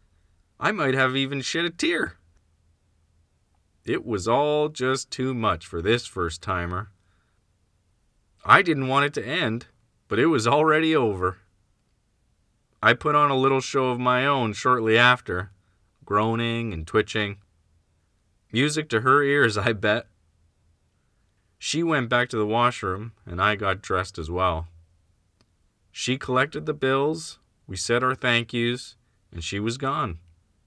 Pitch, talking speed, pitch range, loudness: 110 Hz, 145 wpm, 90-130 Hz, -23 LUFS